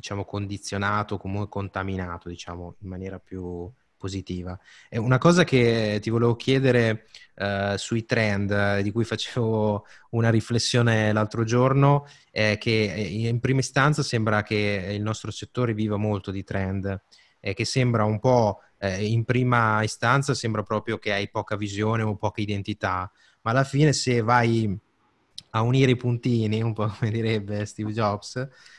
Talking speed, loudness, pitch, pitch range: 150 wpm, -24 LUFS, 110 Hz, 100-120 Hz